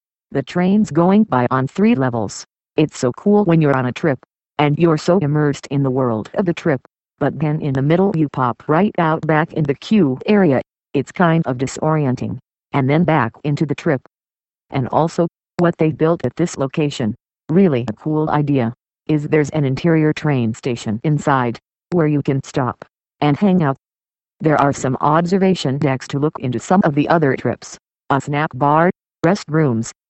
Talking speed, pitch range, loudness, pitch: 185 wpm, 135-165 Hz, -17 LUFS, 150 Hz